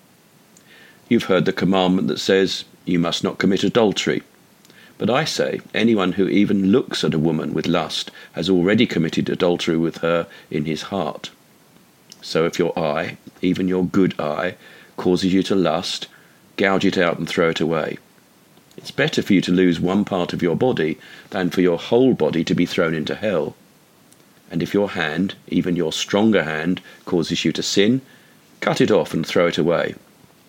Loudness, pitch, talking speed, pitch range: -20 LUFS, 90 Hz, 180 wpm, 85-95 Hz